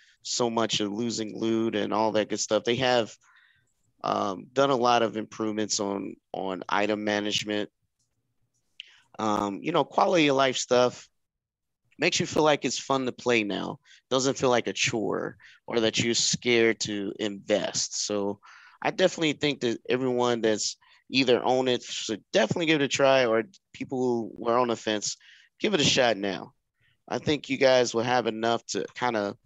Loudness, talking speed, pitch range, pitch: -26 LUFS, 175 wpm, 110-130 Hz, 120 Hz